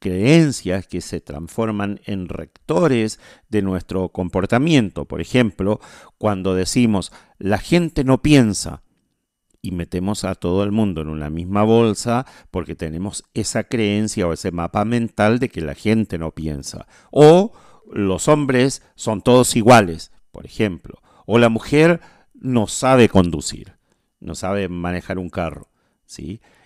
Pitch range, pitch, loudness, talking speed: 90-120 Hz, 100 Hz, -18 LUFS, 135 wpm